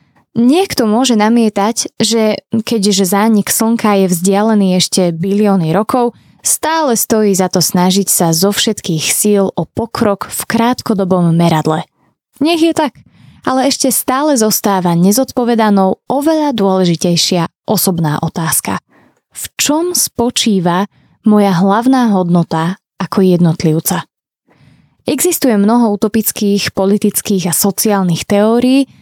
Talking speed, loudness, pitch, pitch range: 110 wpm, -12 LUFS, 205 Hz, 185-235 Hz